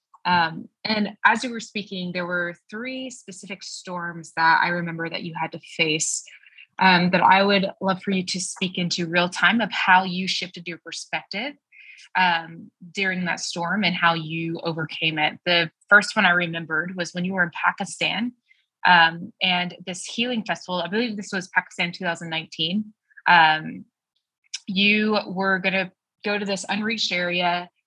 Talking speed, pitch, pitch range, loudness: 170 wpm, 185 Hz, 175-205 Hz, -22 LUFS